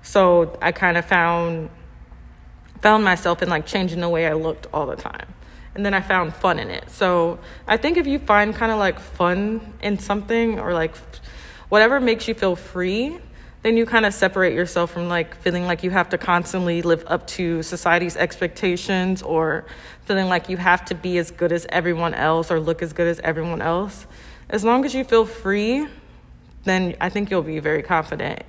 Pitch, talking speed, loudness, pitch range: 180 Hz, 200 wpm, -20 LUFS, 170-200 Hz